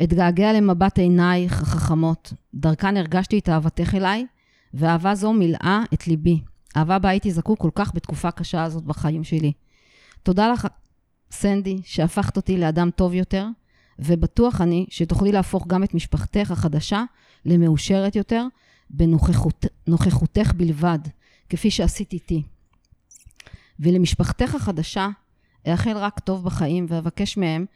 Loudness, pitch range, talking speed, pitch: -21 LUFS, 160-195 Hz, 125 wpm, 175 Hz